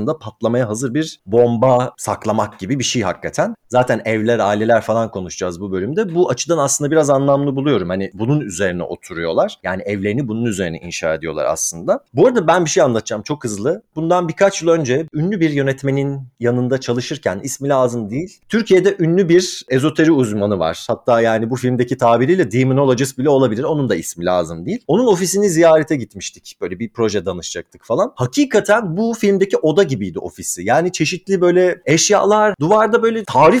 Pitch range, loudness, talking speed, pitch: 115-165 Hz, -16 LUFS, 170 wpm, 135 Hz